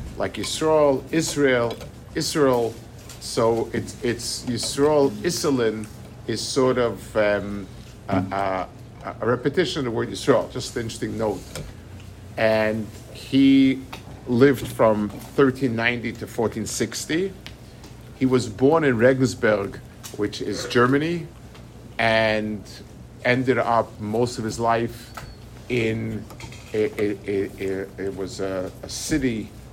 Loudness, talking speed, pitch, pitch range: -23 LUFS, 115 wpm, 115 Hz, 110-125 Hz